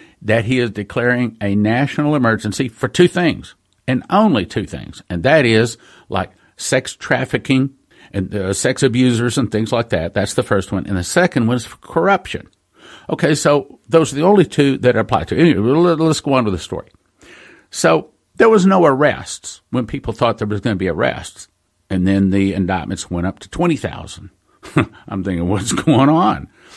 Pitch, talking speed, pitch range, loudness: 115 Hz, 190 wpm, 100-135 Hz, -16 LUFS